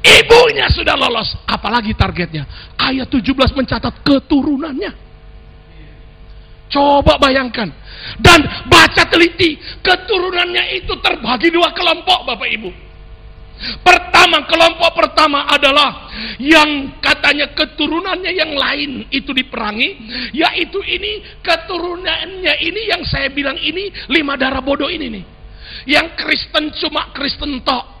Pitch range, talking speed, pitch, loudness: 265-345 Hz, 105 wpm, 300 Hz, -13 LUFS